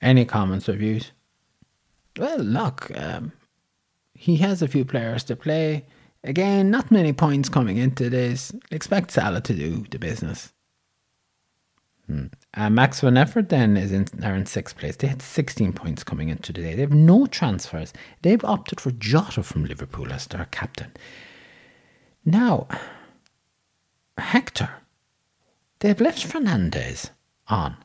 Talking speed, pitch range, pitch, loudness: 140 wpm, 105-160 Hz, 130 Hz, -23 LUFS